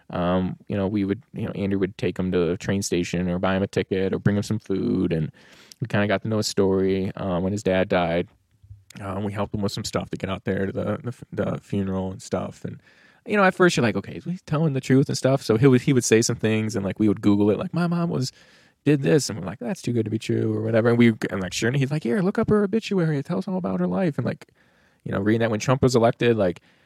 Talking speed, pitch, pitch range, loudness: 300 wpm, 110 Hz, 95-135 Hz, -23 LUFS